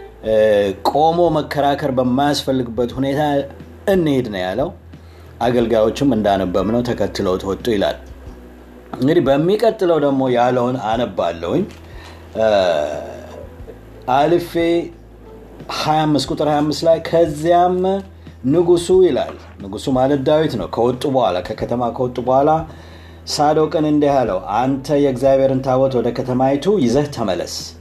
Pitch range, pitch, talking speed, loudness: 105-150 Hz, 130 Hz, 95 wpm, -17 LUFS